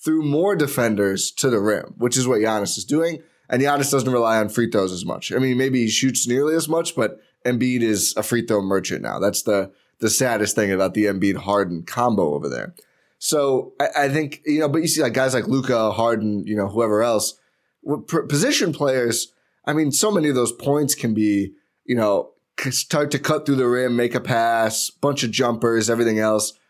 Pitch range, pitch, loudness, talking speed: 110-140 Hz, 120 Hz, -20 LUFS, 210 wpm